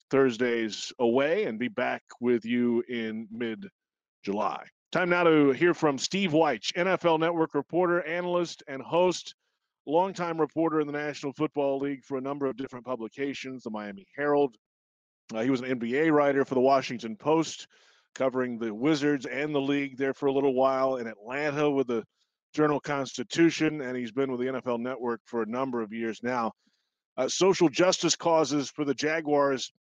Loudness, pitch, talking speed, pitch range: -28 LUFS, 140 Hz, 175 wpm, 125-155 Hz